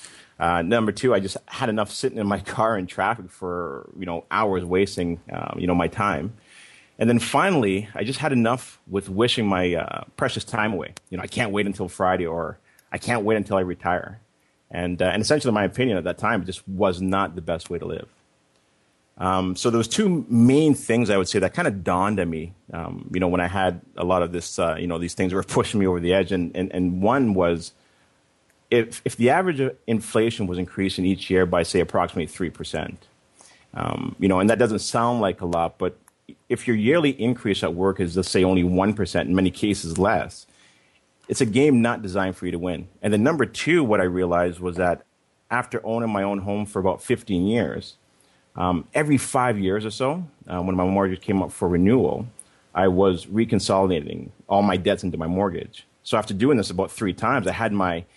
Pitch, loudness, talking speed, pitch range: 95 Hz, -23 LUFS, 220 wpm, 90-115 Hz